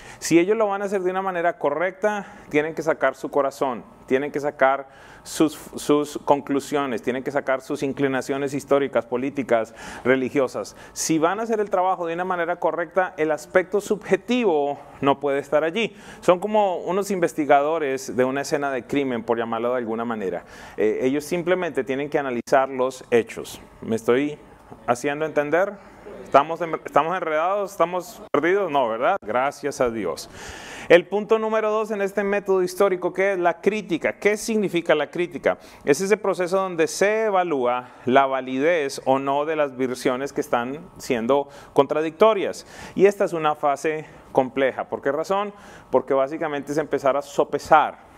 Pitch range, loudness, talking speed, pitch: 140-190 Hz, -23 LUFS, 160 wpm, 155 Hz